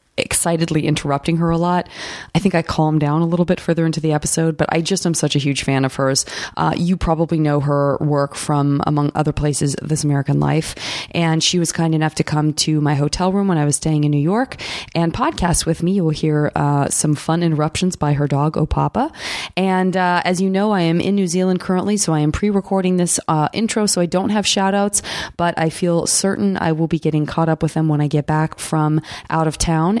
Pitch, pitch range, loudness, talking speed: 160 Hz, 150-180 Hz, -18 LUFS, 240 wpm